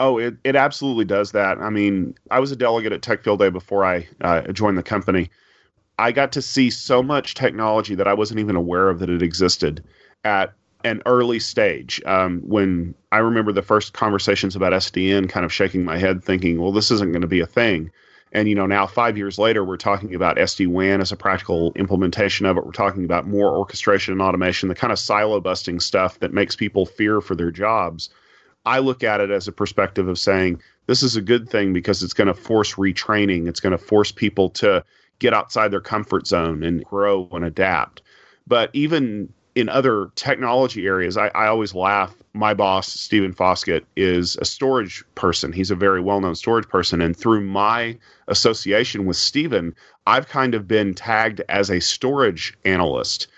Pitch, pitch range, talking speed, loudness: 100 Hz, 90-110 Hz, 200 wpm, -20 LUFS